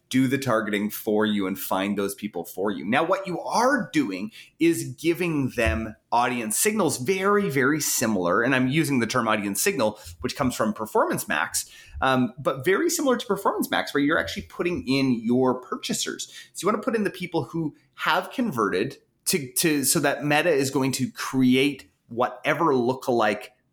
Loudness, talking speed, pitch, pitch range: -24 LUFS, 180 wpm, 135 Hz, 115-170 Hz